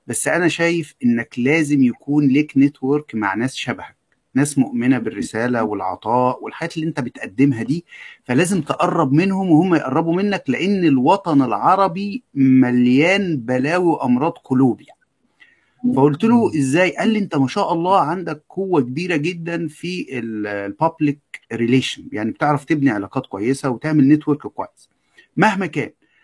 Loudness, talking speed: -18 LUFS, 135 wpm